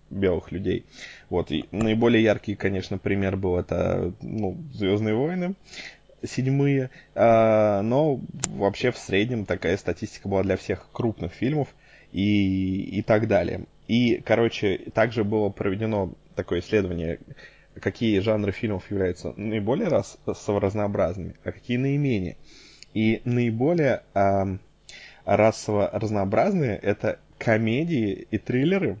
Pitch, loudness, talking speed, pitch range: 105 Hz, -25 LUFS, 115 wpm, 95-115 Hz